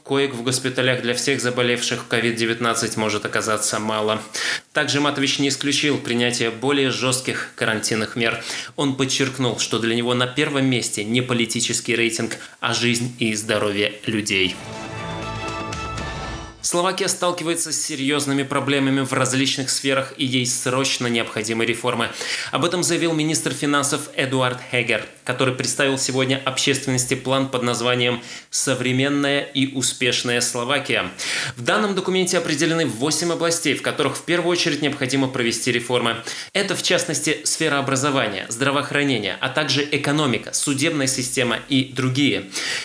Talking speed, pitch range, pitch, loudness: 130 wpm, 120-140 Hz, 130 Hz, -20 LUFS